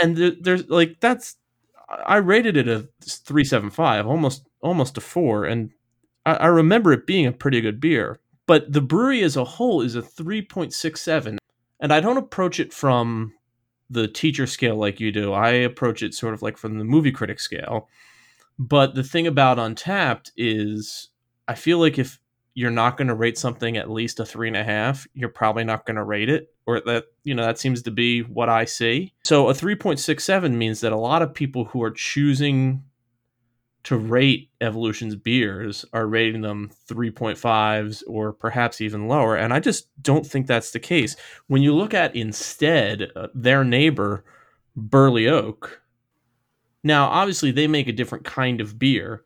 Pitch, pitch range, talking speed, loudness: 125 Hz, 115-150 Hz, 185 wpm, -21 LUFS